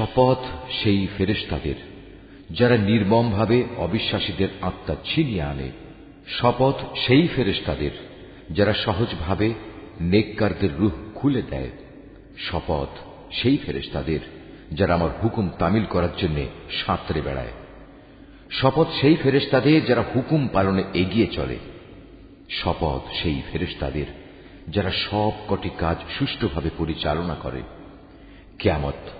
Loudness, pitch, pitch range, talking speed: -23 LUFS, 100 Hz, 85-115 Hz, 100 wpm